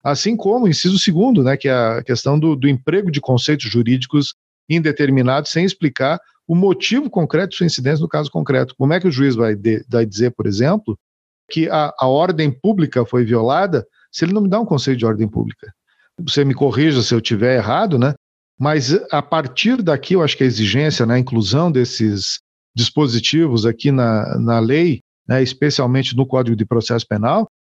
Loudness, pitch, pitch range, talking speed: -16 LUFS, 135 Hz, 120-160 Hz, 195 wpm